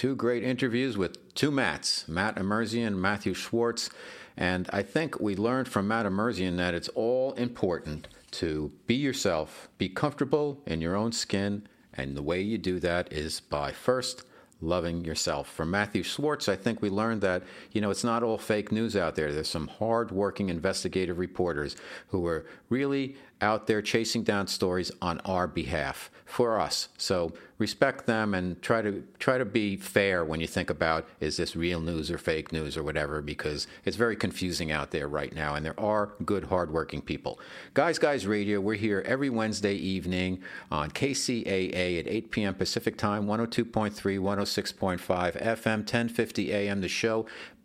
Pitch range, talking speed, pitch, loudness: 90-115 Hz, 175 wpm, 100 Hz, -30 LUFS